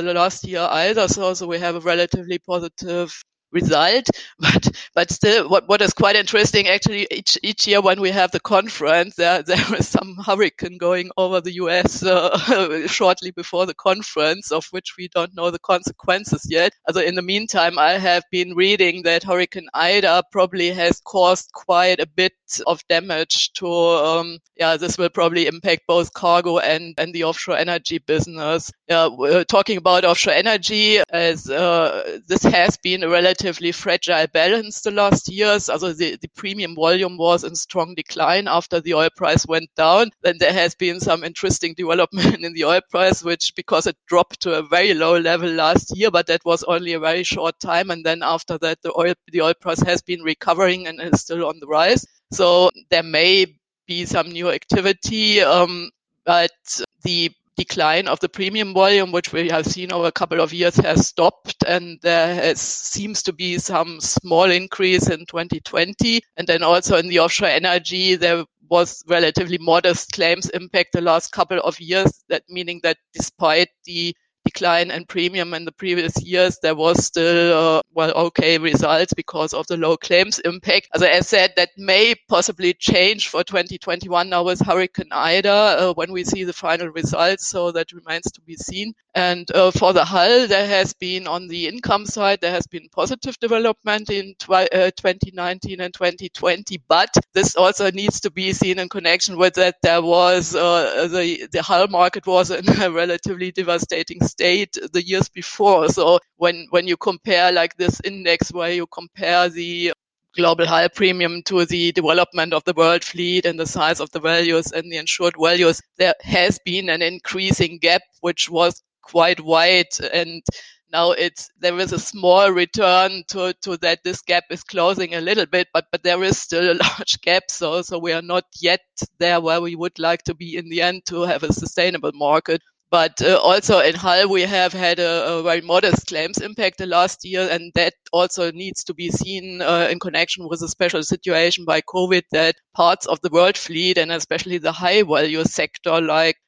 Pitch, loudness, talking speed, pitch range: 175 Hz, -18 LUFS, 185 wpm, 170-185 Hz